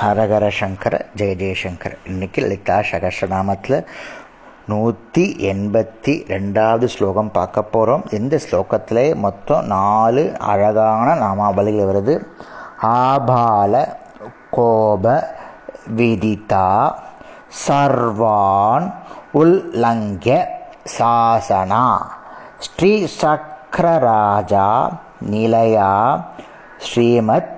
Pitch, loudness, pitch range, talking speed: 110 Hz, -16 LUFS, 100-120 Hz, 65 wpm